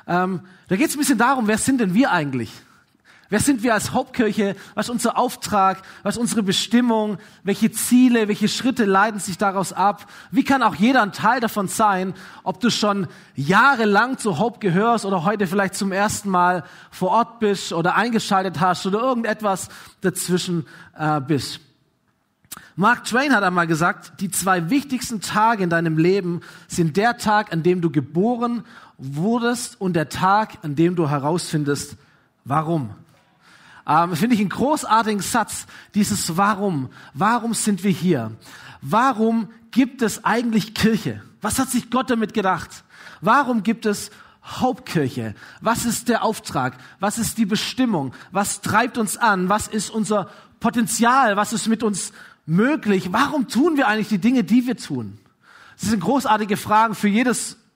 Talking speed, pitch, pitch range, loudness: 160 wpm, 205 Hz, 180-230 Hz, -20 LUFS